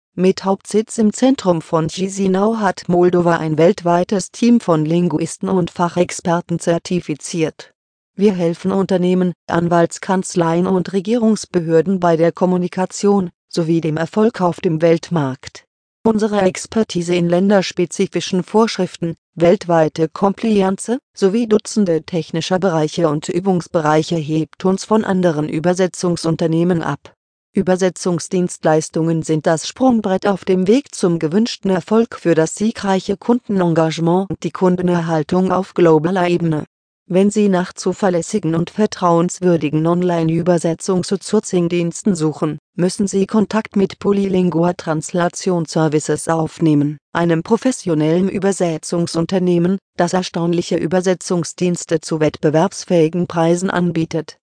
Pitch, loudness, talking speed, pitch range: 175 Hz, -17 LUFS, 110 wpm, 165-195 Hz